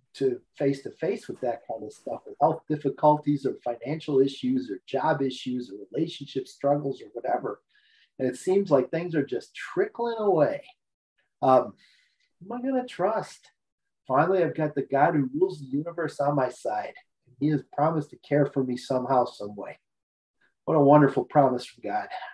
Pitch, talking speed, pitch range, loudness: 145 Hz, 185 wpm, 135-185 Hz, -26 LUFS